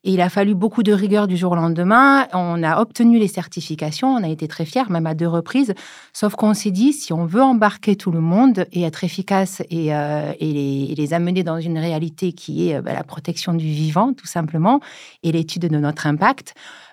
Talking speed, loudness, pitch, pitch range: 220 wpm, -19 LUFS, 175 Hz, 165-210 Hz